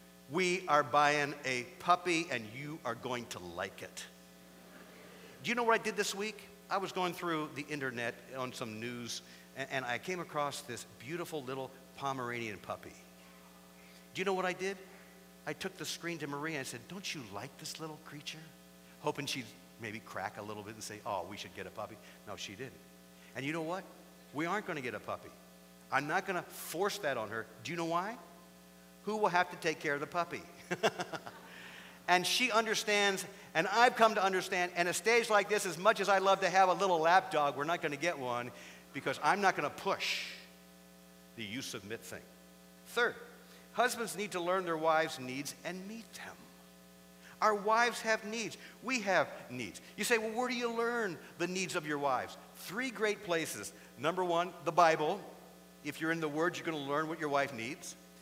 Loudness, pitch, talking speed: -34 LUFS, 150 Hz, 205 wpm